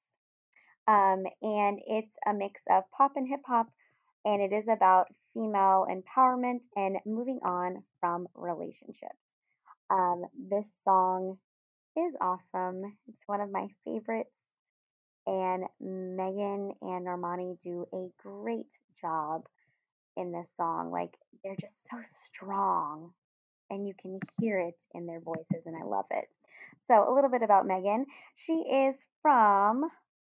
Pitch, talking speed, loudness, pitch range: 195 Hz, 135 wpm, -30 LUFS, 185-225 Hz